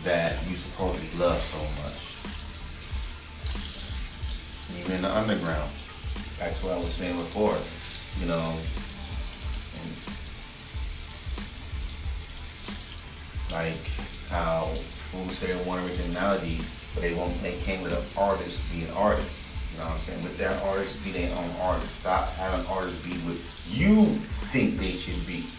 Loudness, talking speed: -30 LUFS, 140 wpm